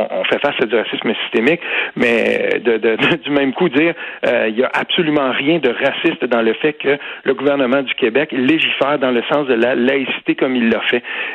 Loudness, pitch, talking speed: -16 LUFS, 145 Hz, 220 wpm